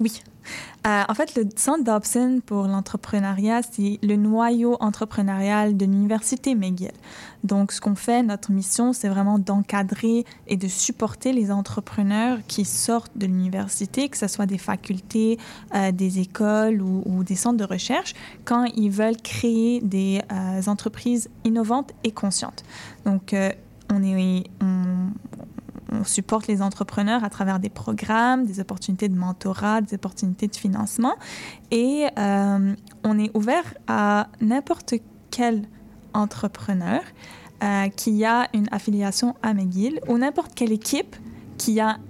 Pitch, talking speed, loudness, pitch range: 210 Hz, 145 wpm, -23 LUFS, 200-230 Hz